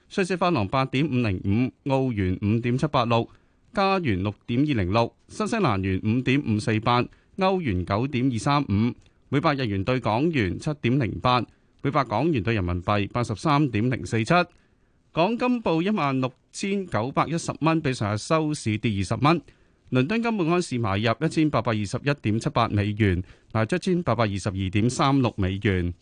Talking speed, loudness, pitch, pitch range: 275 characters per minute, -24 LUFS, 125 Hz, 105-150 Hz